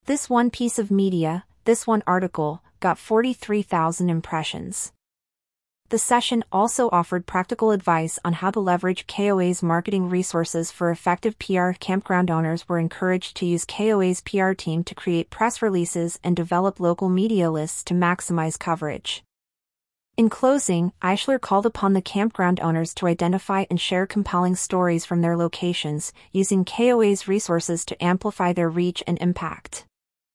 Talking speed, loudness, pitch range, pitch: 145 wpm, -23 LUFS, 170-205 Hz, 180 Hz